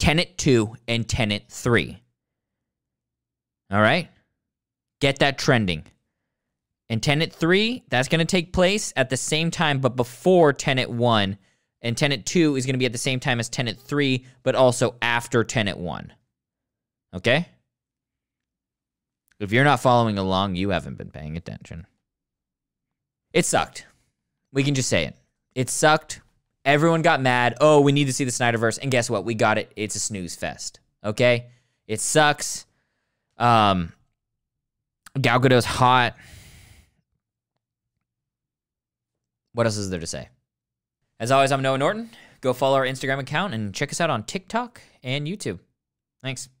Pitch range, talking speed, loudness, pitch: 110-145 Hz, 150 wpm, -22 LUFS, 125 Hz